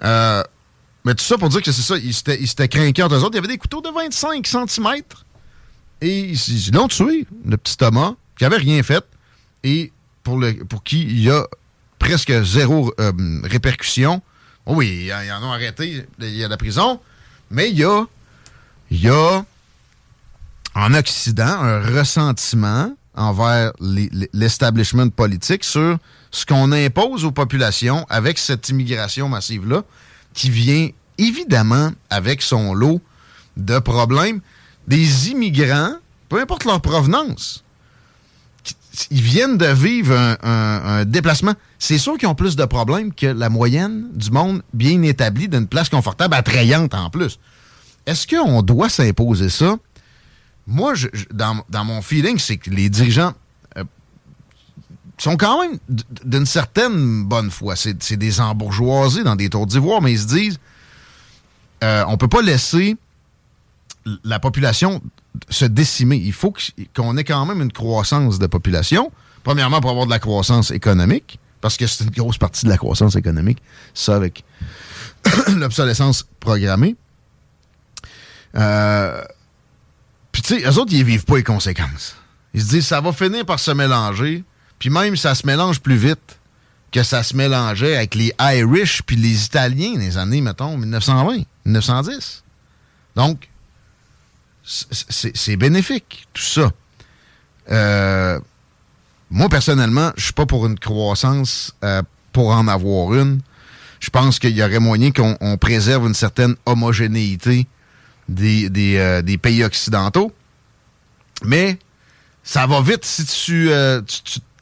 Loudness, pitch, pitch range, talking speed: -17 LUFS, 125 Hz, 110-150 Hz, 155 wpm